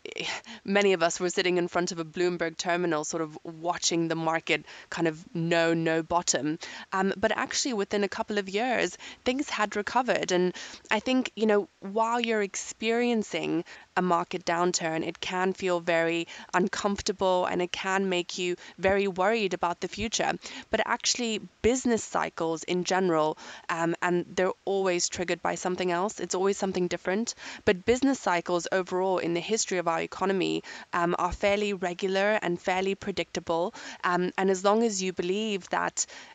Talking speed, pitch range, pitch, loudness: 165 wpm, 175-205 Hz, 185 Hz, -28 LUFS